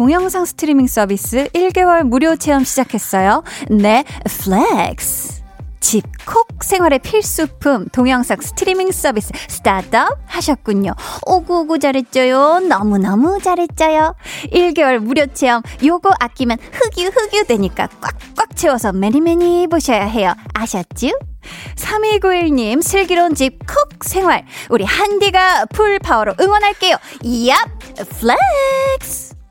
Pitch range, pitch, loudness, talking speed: 245-360 Hz, 300 Hz, -14 LUFS, 275 characters per minute